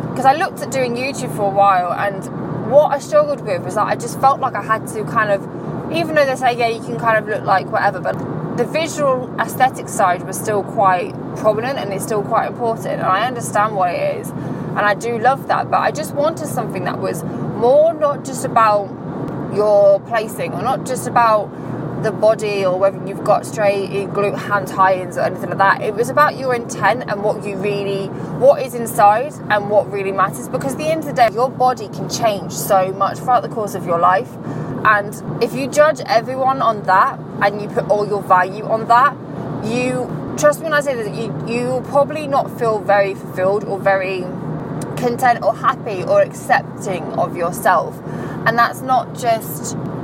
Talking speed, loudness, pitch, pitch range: 205 wpm, -17 LUFS, 210 Hz, 195-250 Hz